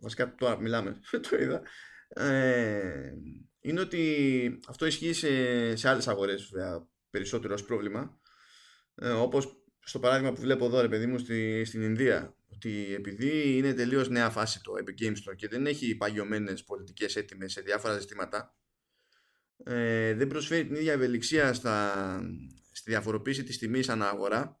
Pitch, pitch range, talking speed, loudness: 120 Hz, 105-135 Hz, 155 wpm, -30 LUFS